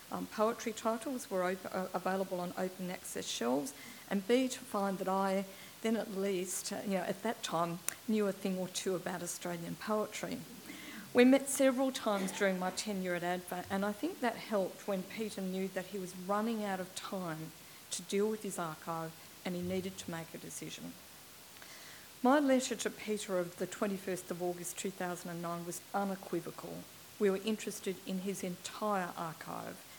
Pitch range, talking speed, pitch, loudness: 180-215 Hz, 180 wpm, 195 Hz, -36 LUFS